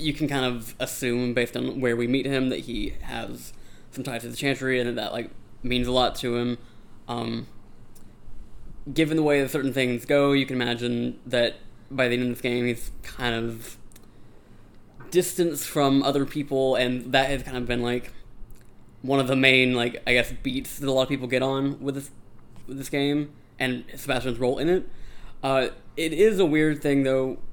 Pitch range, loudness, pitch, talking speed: 120-135 Hz, -25 LUFS, 130 Hz, 200 wpm